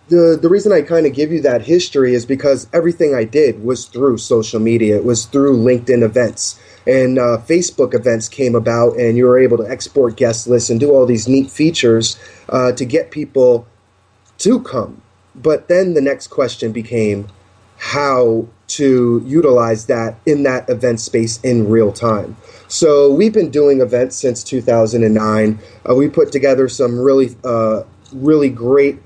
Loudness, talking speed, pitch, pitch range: -14 LUFS, 170 wpm, 125 Hz, 115-140 Hz